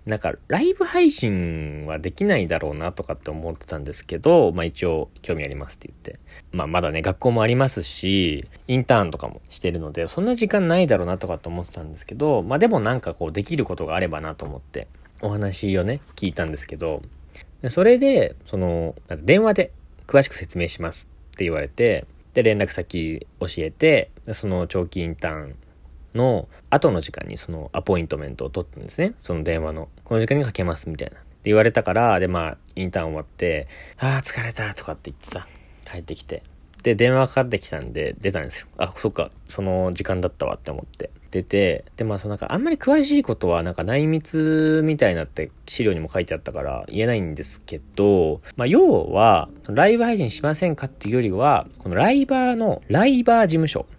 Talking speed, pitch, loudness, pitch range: 410 characters per minute, 95 Hz, -22 LUFS, 80-125 Hz